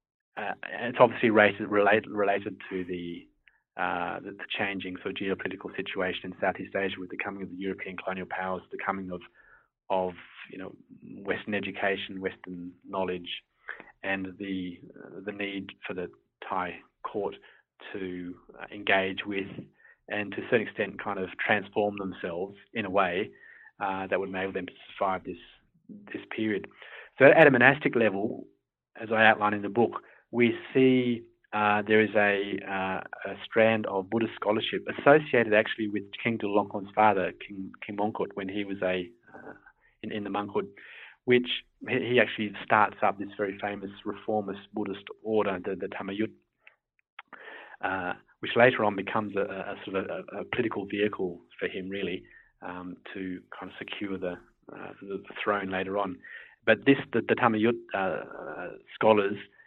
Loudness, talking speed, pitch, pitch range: -28 LUFS, 165 wpm, 100 Hz, 95-110 Hz